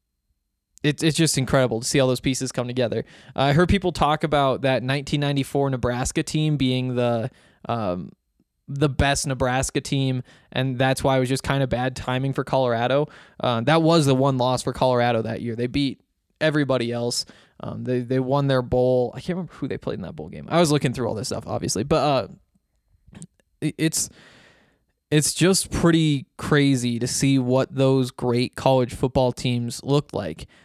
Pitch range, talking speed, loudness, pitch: 125-145 Hz, 180 wpm, -22 LUFS, 130 Hz